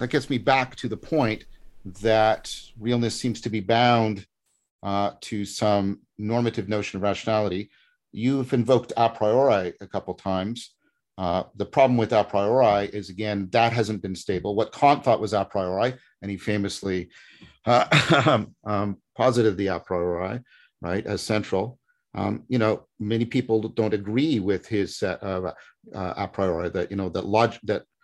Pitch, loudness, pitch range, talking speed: 110 Hz, -24 LUFS, 100-120 Hz, 165 wpm